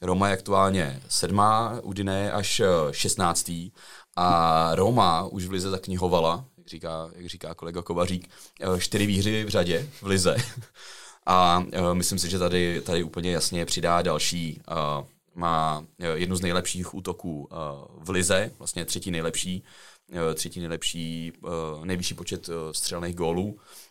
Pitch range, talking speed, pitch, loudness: 85-95 Hz, 130 wpm, 90 Hz, -26 LUFS